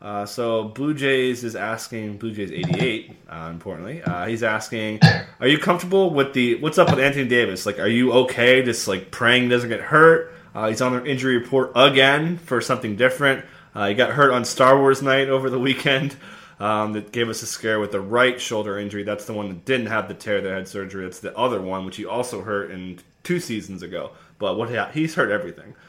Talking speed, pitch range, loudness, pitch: 220 wpm, 105-135 Hz, -20 LUFS, 120 Hz